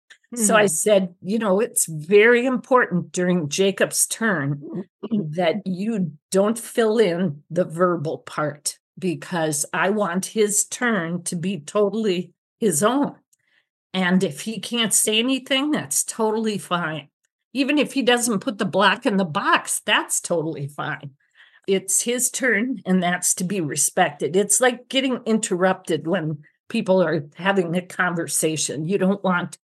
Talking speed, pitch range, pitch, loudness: 145 wpm, 175-220 Hz, 190 Hz, -21 LUFS